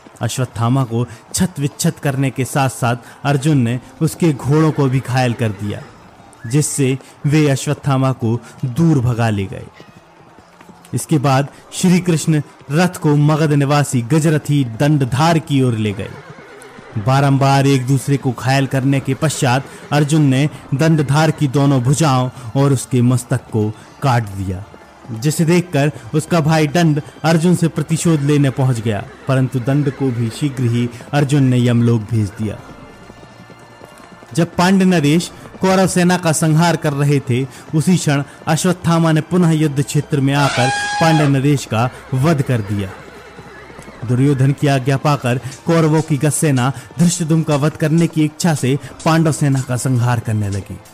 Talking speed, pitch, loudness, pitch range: 150 wpm, 140 Hz, -16 LUFS, 125-155 Hz